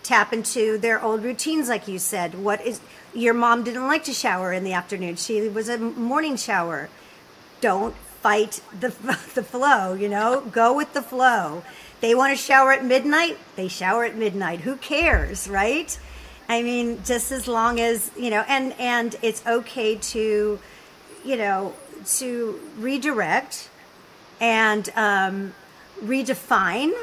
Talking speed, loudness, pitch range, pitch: 150 wpm, -22 LUFS, 210-255 Hz, 230 Hz